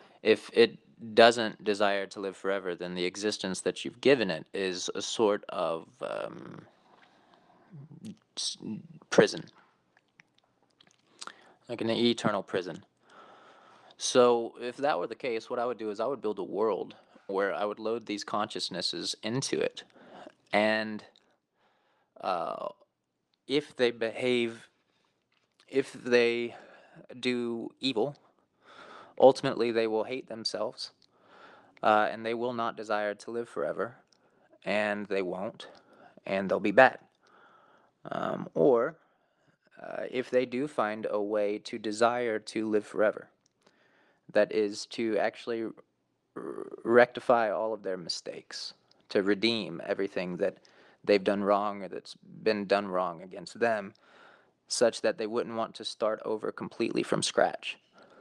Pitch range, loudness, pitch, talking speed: 105-120 Hz, -30 LUFS, 110 Hz, 130 wpm